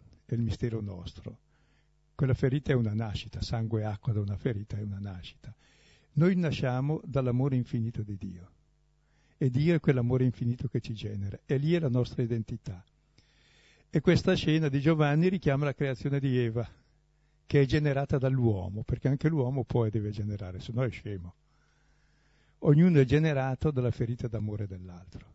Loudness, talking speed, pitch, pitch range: -29 LUFS, 165 wpm, 125 Hz, 110-145 Hz